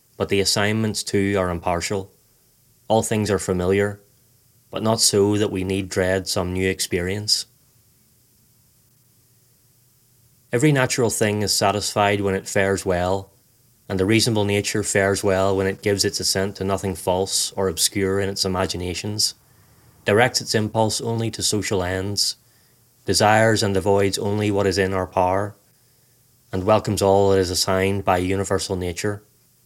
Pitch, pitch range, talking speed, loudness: 100 Hz, 95-115 Hz, 150 wpm, -21 LUFS